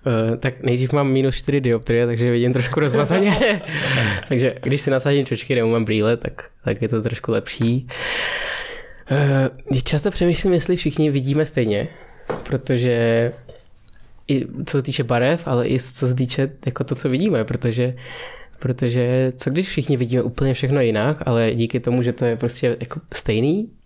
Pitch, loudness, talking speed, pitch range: 130 Hz, -20 LUFS, 165 wpm, 120-140 Hz